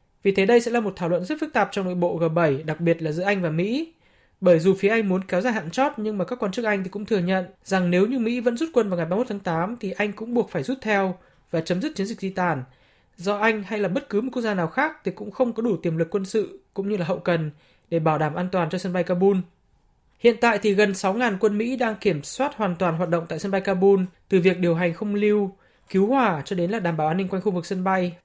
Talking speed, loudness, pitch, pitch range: 295 wpm, -23 LUFS, 195 Hz, 175-220 Hz